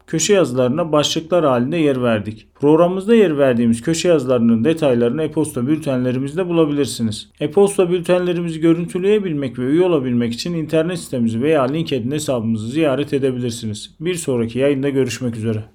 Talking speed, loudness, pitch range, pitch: 130 wpm, -17 LUFS, 125-165 Hz, 145 Hz